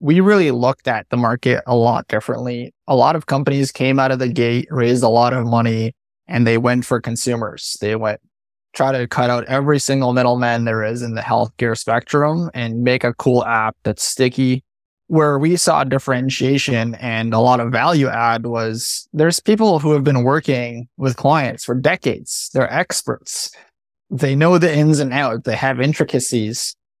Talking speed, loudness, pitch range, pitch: 180 wpm, -17 LUFS, 115-140 Hz, 125 Hz